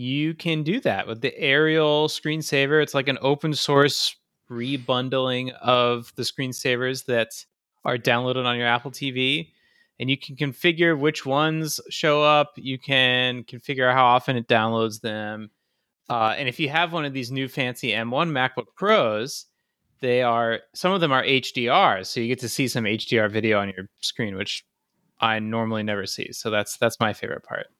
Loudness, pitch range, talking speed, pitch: -23 LUFS, 120-150 Hz, 175 wpm, 130 Hz